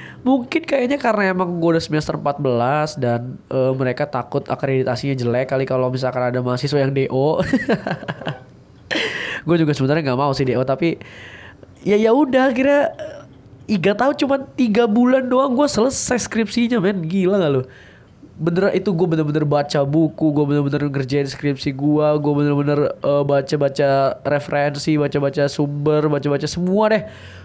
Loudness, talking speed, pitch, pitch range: -19 LUFS, 150 wpm, 150 Hz, 135-200 Hz